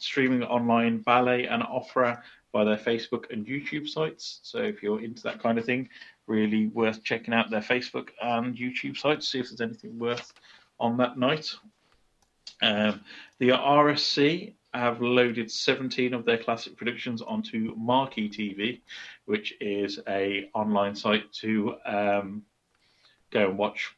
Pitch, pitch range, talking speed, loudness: 120 Hz, 110-125 Hz, 150 wpm, -27 LUFS